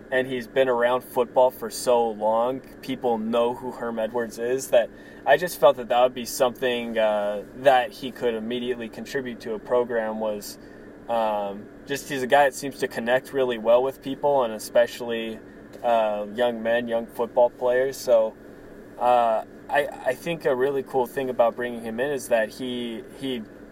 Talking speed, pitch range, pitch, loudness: 180 wpm, 115-130 Hz, 120 Hz, -24 LUFS